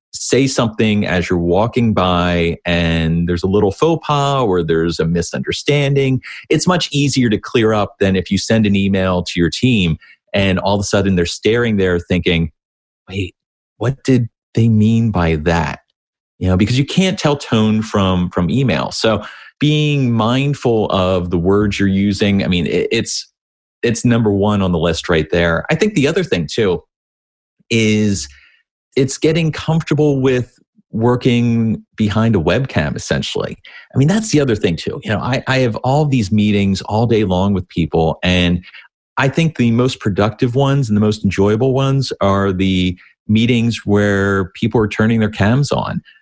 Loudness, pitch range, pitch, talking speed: -15 LUFS, 90-130 Hz, 105 Hz, 175 wpm